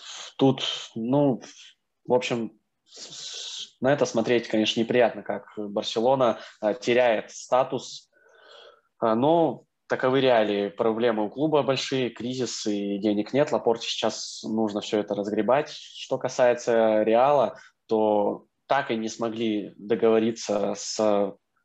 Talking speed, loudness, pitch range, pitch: 110 wpm, -25 LUFS, 105-125 Hz, 110 Hz